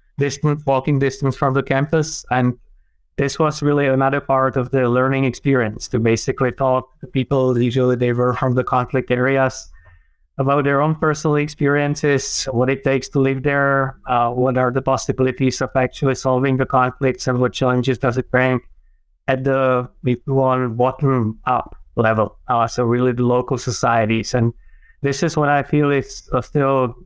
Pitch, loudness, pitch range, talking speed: 130 Hz, -18 LUFS, 125-140 Hz, 165 wpm